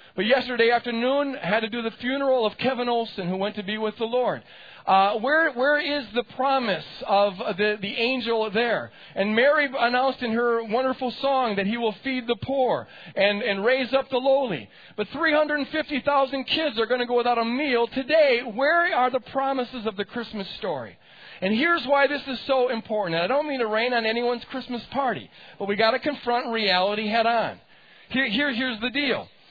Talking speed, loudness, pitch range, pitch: 200 wpm, -24 LUFS, 225-270 Hz, 245 Hz